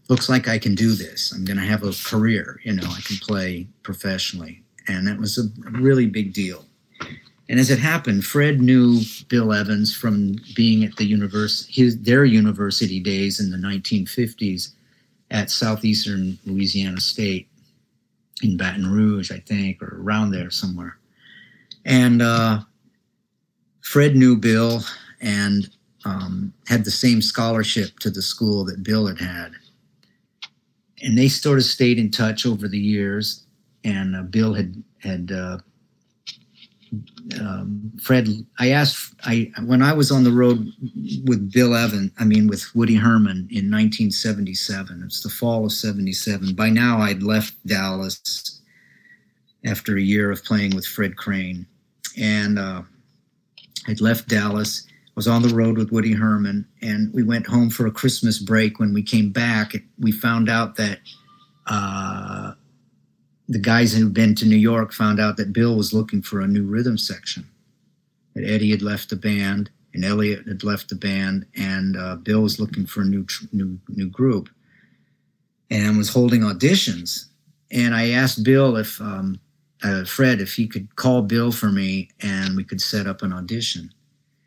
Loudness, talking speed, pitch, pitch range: -20 LUFS, 165 wpm, 105 Hz, 100-115 Hz